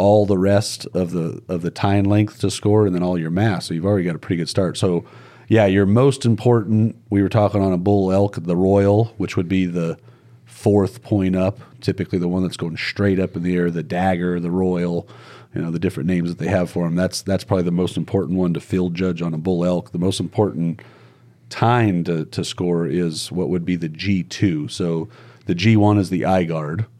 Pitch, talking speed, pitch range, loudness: 95 Hz, 230 wpm, 90-105 Hz, -20 LUFS